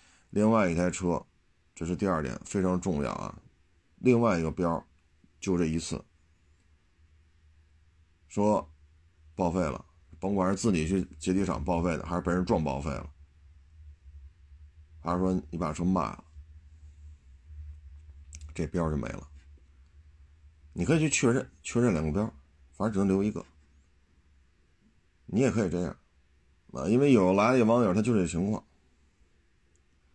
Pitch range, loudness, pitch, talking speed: 75-90 Hz, -29 LUFS, 80 Hz, 195 characters per minute